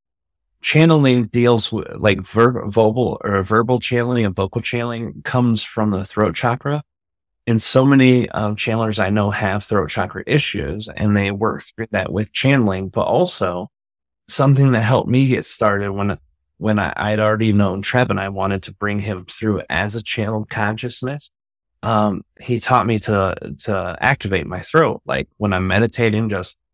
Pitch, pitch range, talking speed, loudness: 110 Hz, 100-120 Hz, 165 wpm, -18 LUFS